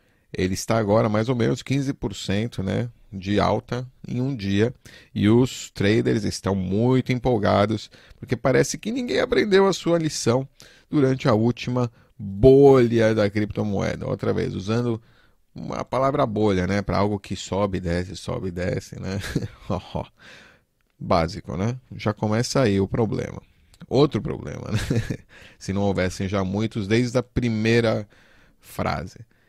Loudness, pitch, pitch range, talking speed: -23 LUFS, 115 Hz, 100-125 Hz, 140 wpm